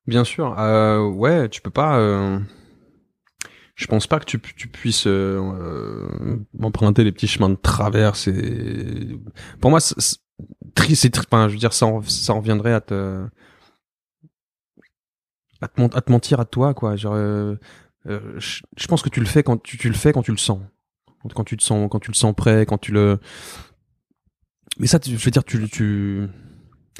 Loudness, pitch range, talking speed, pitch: -19 LUFS, 105-120 Hz, 190 wpm, 110 Hz